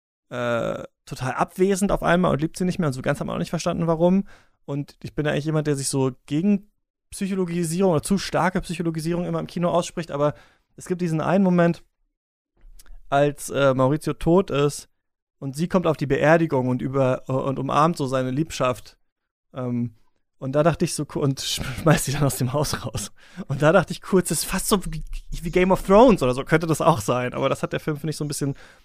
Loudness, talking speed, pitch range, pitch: -22 LUFS, 225 wpm, 135-175 Hz, 155 Hz